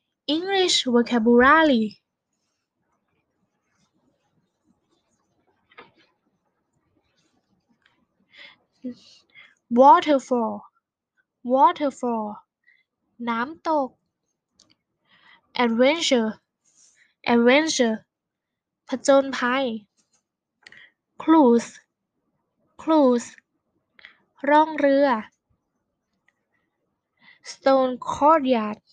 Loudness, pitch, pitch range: -20 LUFS, 260 Hz, 240-310 Hz